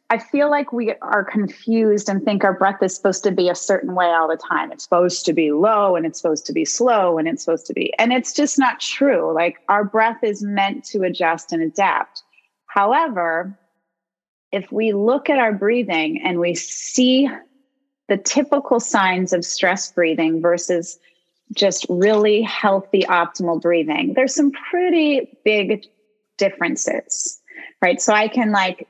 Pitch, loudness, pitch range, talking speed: 200 Hz, -18 LUFS, 175-240 Hz, 170 wpm